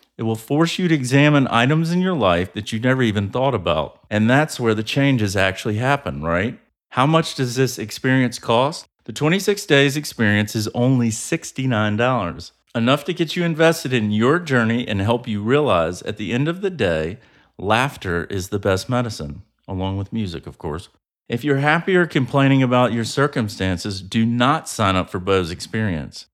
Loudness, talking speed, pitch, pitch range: -19 LUFS, 180 wpm, 120 Hz, 105-140 Hz